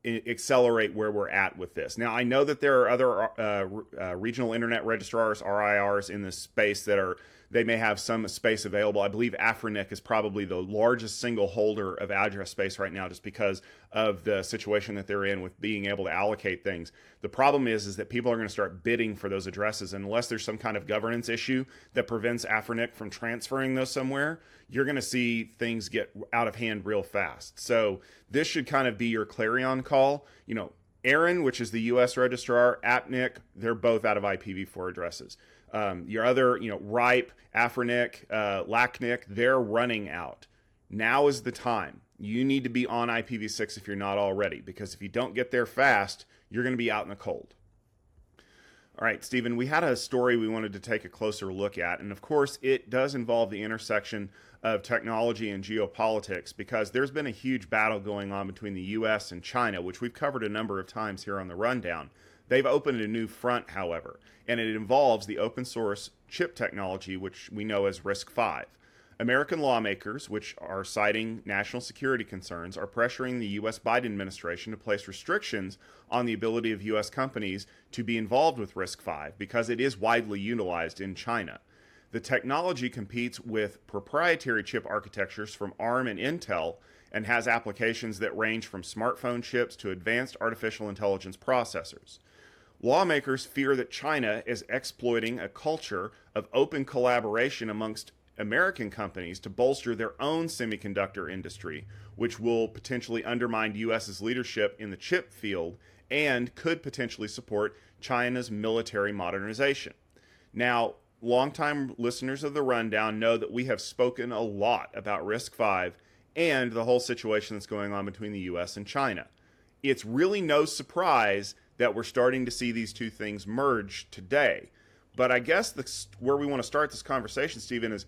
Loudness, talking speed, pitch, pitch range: -29 LUFS, 180 wpm, 115 Hz, 100-125 Hz